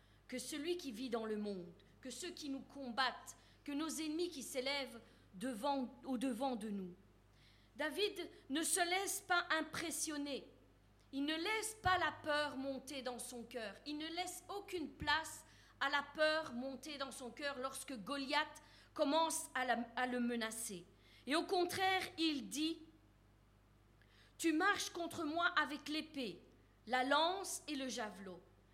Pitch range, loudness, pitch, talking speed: 245-320 Hz, -40 LUFS, 280 Hz, 155 wpm